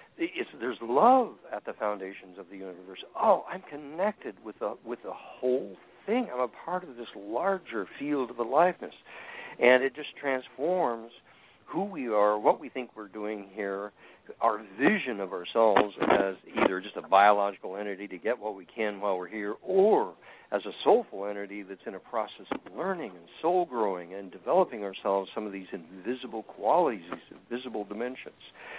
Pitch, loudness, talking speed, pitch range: 110 Hz, -29 LUFS, 185 wpm, 100-145 Hz